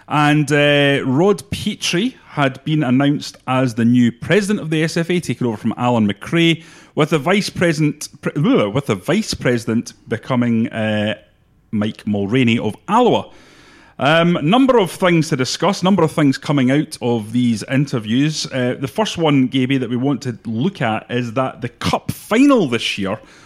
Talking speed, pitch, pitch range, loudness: 170 wpm, 140 Hz, 120-165 Hz, -17 LUFS